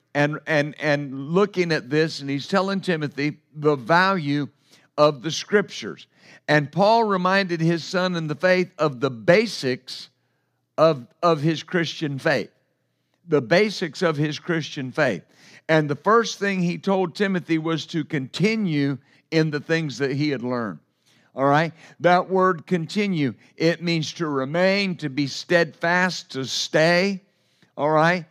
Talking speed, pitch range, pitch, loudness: 150 wpm, 145-180 Hz, 160 Hz, -22 LUFS